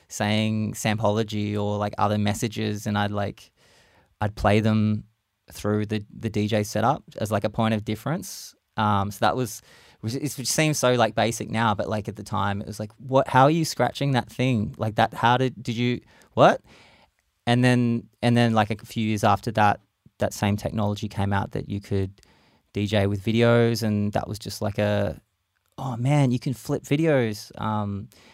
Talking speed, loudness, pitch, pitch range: 190 wpm, -24 LUFS, 110 Hz, 105-120 Hz